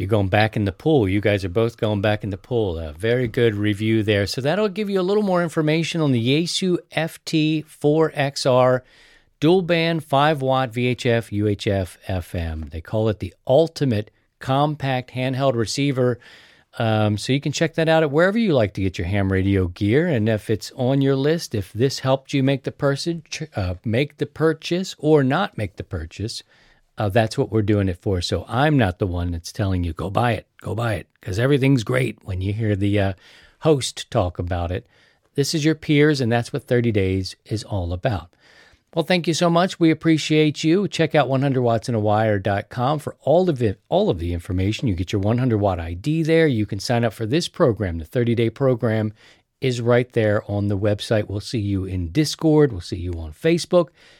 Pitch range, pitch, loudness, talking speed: 105-150 Hz, 120 Hz, -21 LUFS, 205 wpm